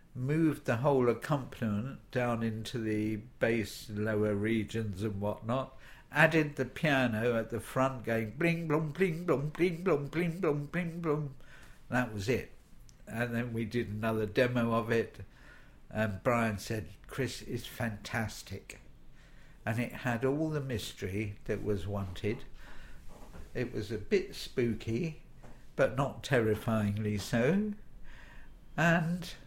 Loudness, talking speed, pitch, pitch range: -33 LUFS, 130 wpm, 120 Hz, 110-145 Hz